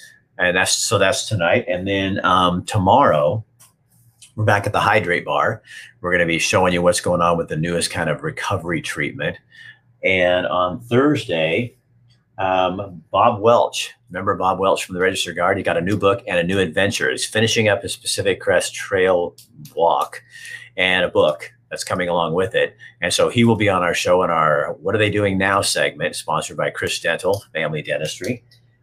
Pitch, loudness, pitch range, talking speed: 105 Hz, -19 LUFS, 90-125 Hz, 190 wpm